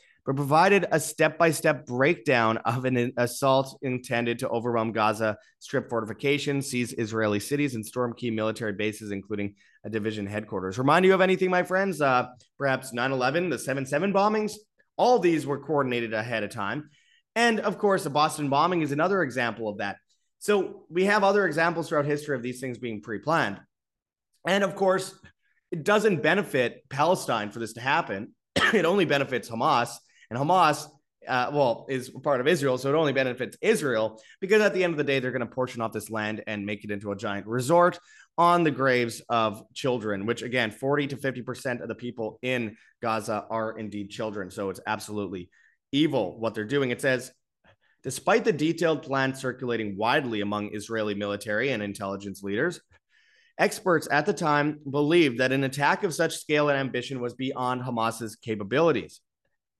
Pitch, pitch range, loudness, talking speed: 130 Hz, 110-160 Hz, -26 LUFS, 180 wpm